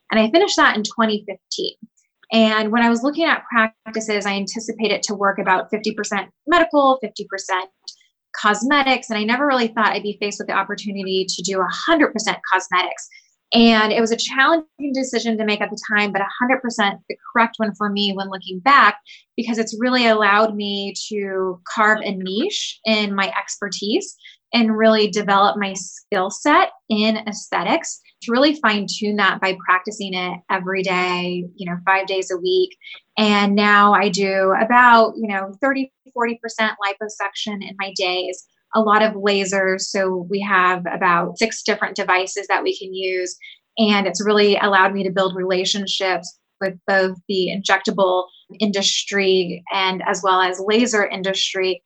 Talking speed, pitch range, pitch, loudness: 165 wpm, 190-225 Hz, 205 Hz, -18 LUFS